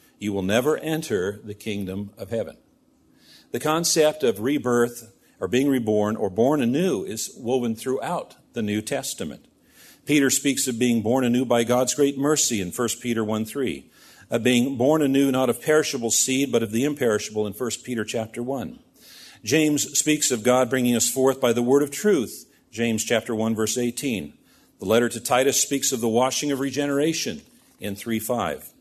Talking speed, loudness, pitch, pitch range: 180 wpm, -23 LUFS, 125 Hz, 115-140 Hz